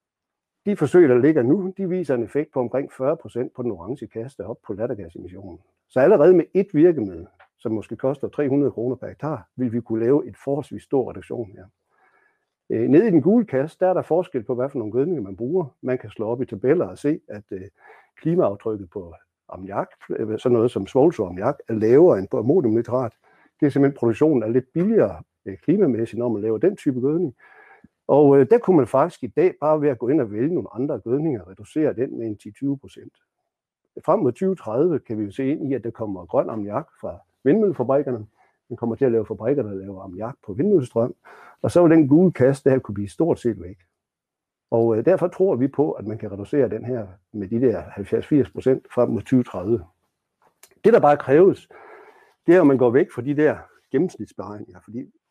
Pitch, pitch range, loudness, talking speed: 130 Hz, 110-150 Hz, -21 LUFS, 205 wpm